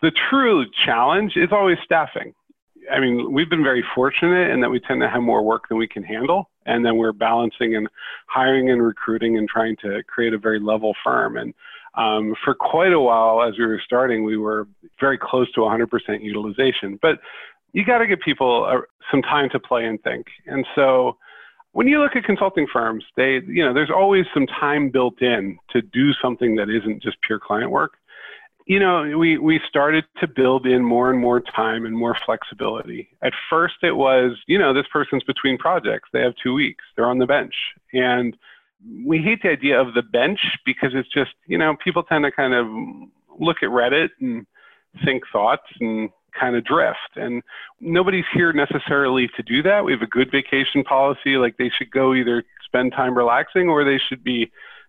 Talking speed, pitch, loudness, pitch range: 200 wpm, 130 Hz, -19 LUFS, 115-155 Hz